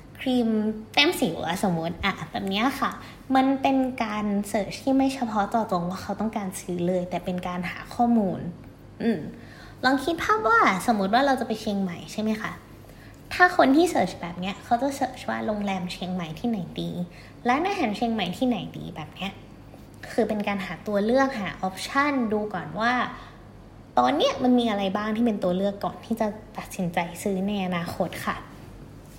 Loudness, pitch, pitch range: -25 LUFS, 210 Hz, 180-240 Hz